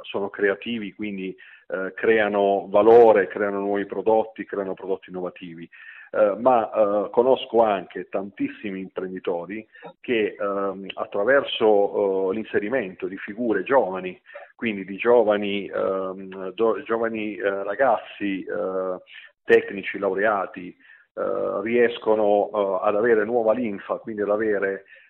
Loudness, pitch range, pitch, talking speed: -23 LUFS, 95-115 Hz, 100 Hz, 115 wpm